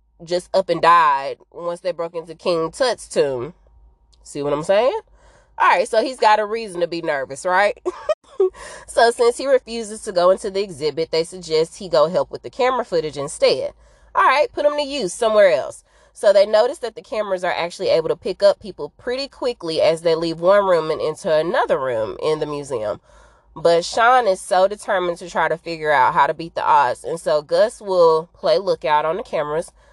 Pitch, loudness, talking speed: 200 Hz, -19 LUFS, 205 wpm